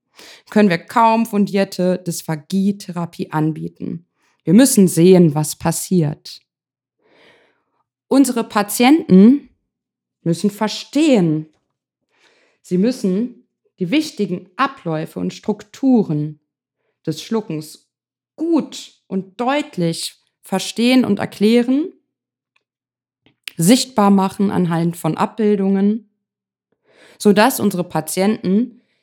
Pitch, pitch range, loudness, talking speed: 205 Hz, 170-240 Hz, -17 LUFS, 80 wpm